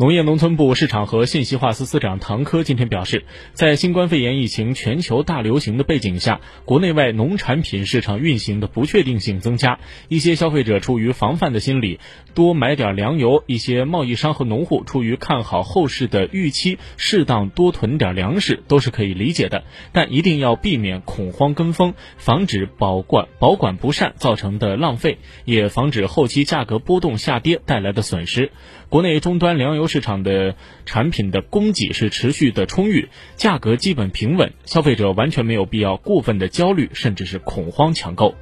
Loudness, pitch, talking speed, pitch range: -18 LUFS, 125 Hz, 290 characters per minute, 105-155 Hz